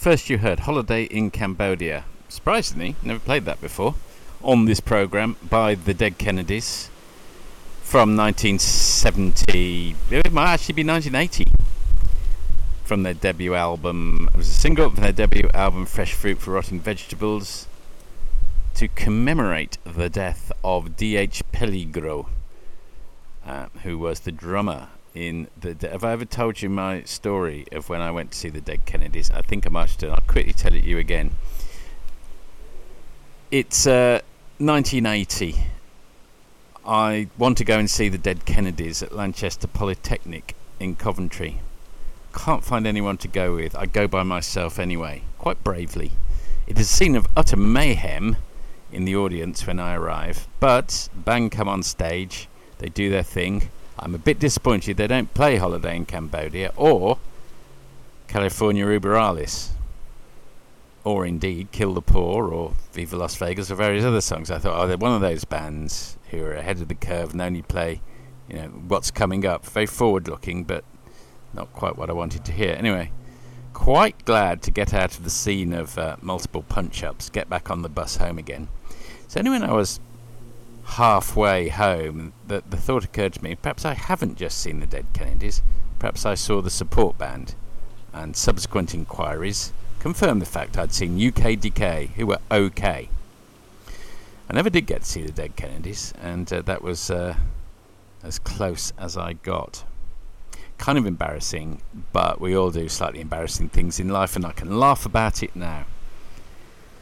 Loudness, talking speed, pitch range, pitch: -23 LUFS, 165 wpm, 85-105 Hz, 95 Hz